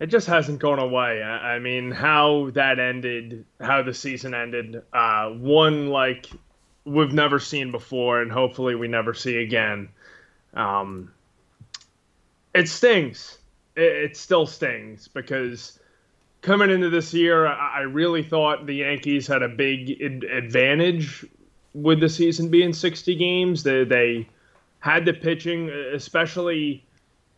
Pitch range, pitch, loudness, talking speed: 120-160 Hz, 140 Hz, -22 LUFS, 130 wpm